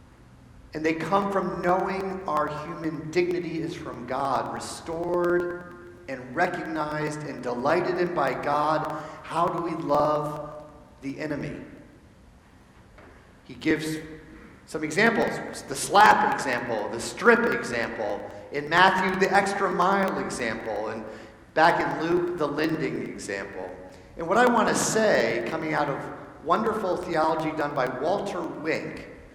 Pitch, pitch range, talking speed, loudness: 155 Hz, 145-175 Hz, 130 wpm, -25 LUFS